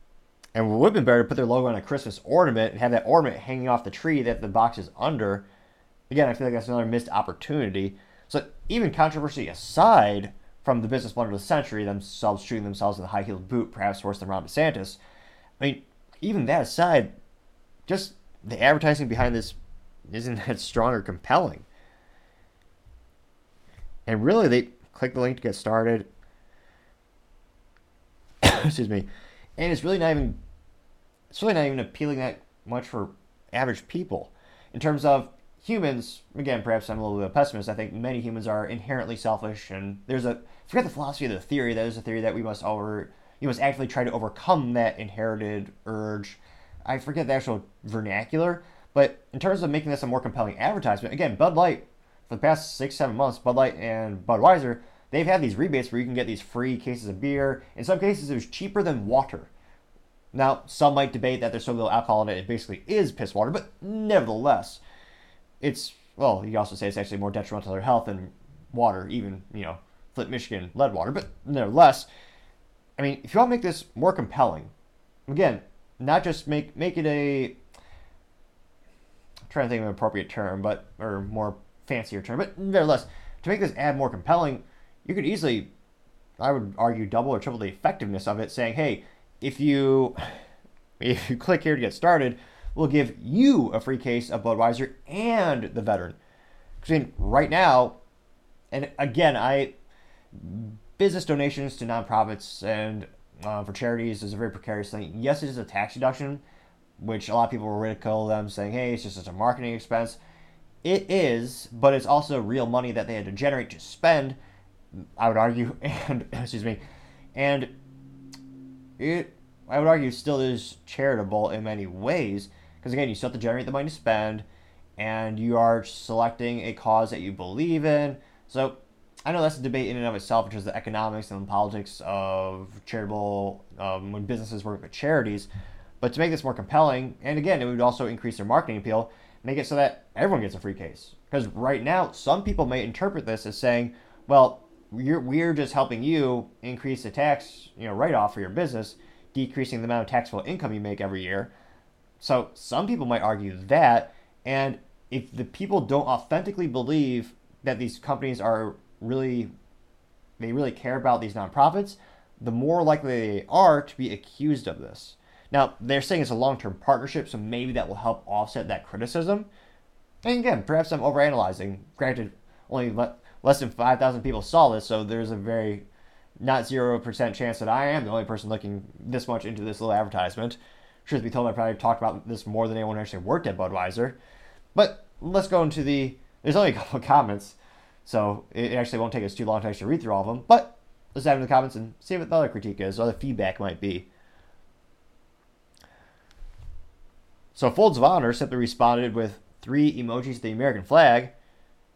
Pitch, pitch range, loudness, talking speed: 115 Hz, 105-135 Hz, -26 LUFS, 190 wpm